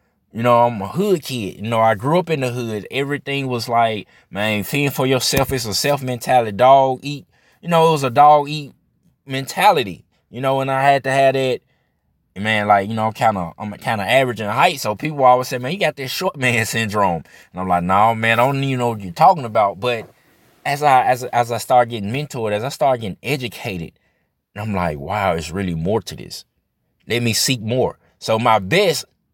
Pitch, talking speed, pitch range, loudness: 120 Hz, 225 wpm, 105-135 Hz, -18 LUFS